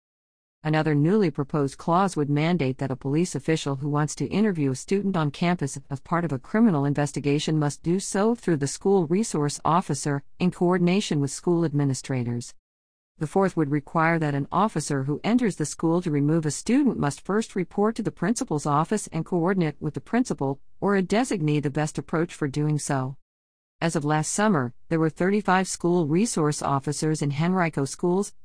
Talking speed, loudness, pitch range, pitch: 180 wpm, -25 LUFS, 145-185 Hz, 155 Hz